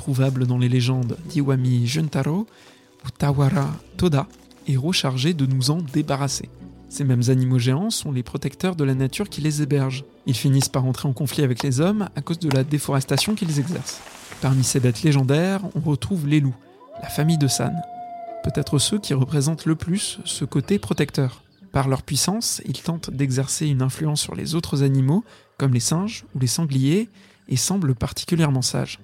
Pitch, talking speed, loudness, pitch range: 145 Hz, 180 wpm, -22 LUFS, 135-165 Hz